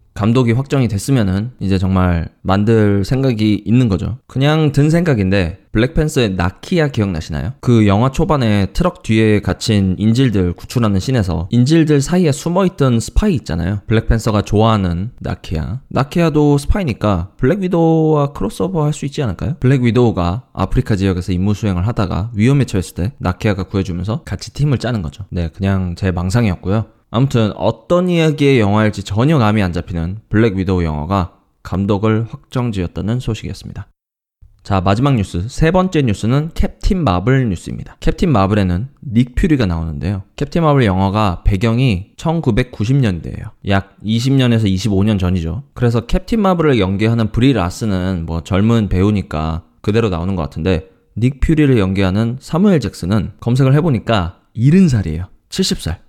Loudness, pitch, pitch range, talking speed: -16 LUFS, 110 Hz, 95-130 Hz, 365 characters per minute